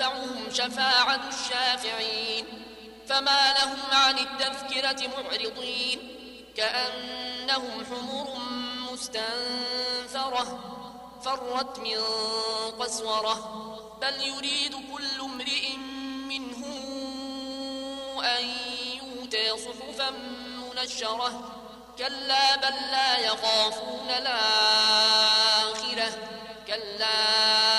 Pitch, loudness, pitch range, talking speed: 250 Hz, -26 LUFS, 225-270 Hz, 60 wpm